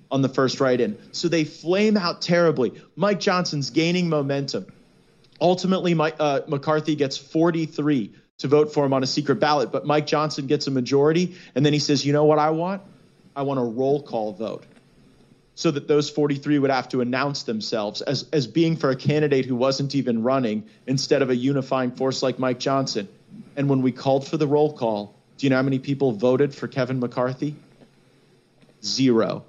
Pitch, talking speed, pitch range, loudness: 145 Hz, 195 wpm, 130-155 Hz, -22 LUFS